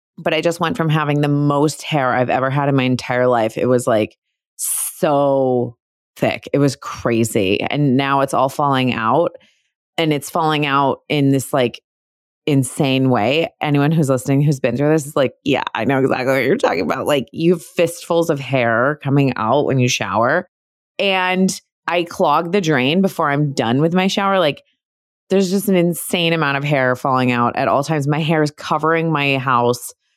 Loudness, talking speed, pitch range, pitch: -17 LUFS, 195 wpm, 130-165 Hz, 145 Hz